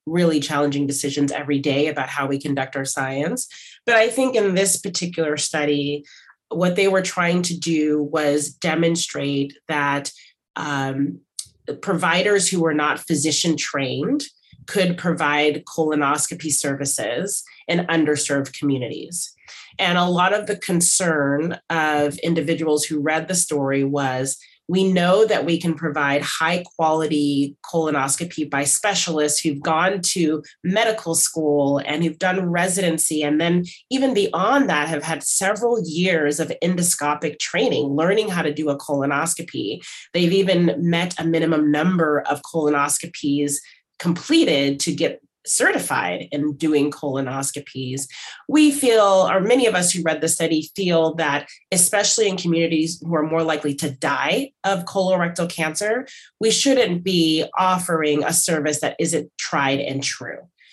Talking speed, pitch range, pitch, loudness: 140 wpm, 145-180 Hz, 160 Hz, -20 LUFS